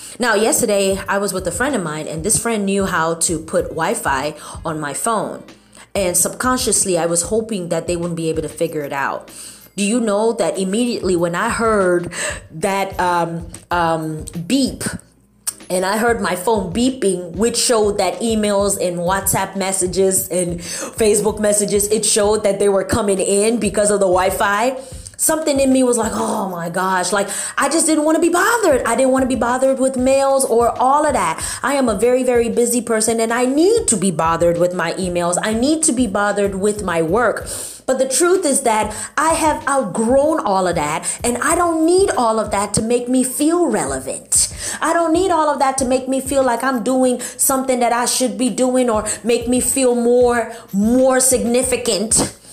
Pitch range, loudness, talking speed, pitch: 190-255 Hz, -17 LUFS, 200 wpm, 225 Hz